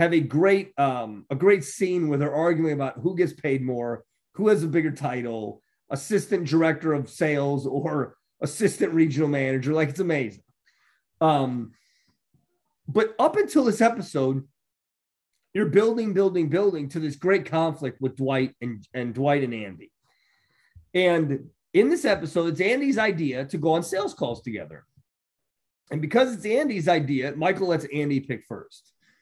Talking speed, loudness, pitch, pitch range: 155 wpm, -24 LUFS, 155 Hz, 135-190 Hz